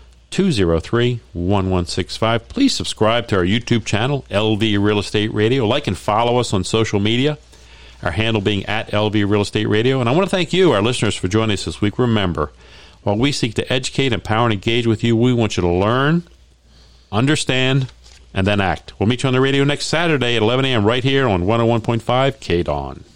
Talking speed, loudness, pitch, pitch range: 200 wpm, -18 LUFS, 110 Hz, 95-125 Hz